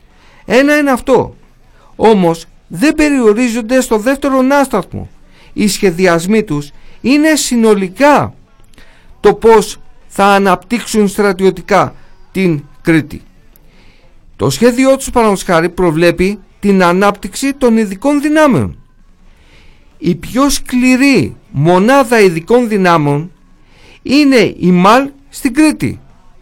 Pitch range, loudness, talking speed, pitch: 175-260 Hz, -11 LUFS, 95 wpm, 210 Hz